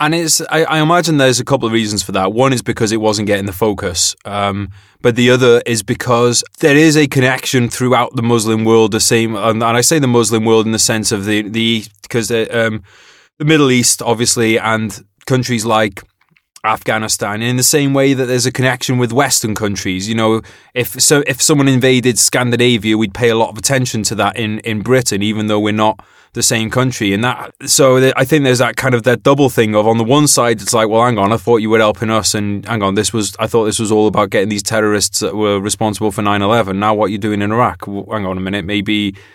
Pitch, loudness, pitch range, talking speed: 115 Hz, -13 LUFS, 105-125 Hz, 240 wpm